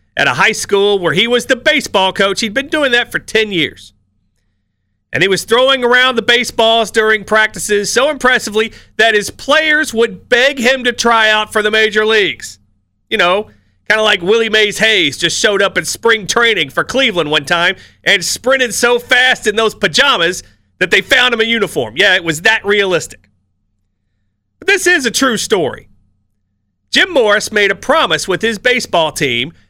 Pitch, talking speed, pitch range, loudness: 215 Hz, 185 wpm, 160-235 Hz, -12 LUFS